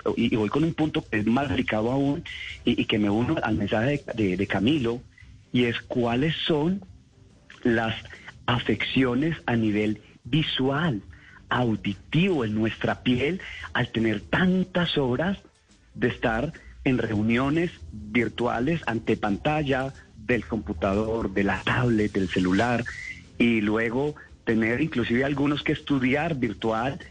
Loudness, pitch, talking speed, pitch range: -25 LUFS, 120 Hz, 135 wpm, 110-140 Hz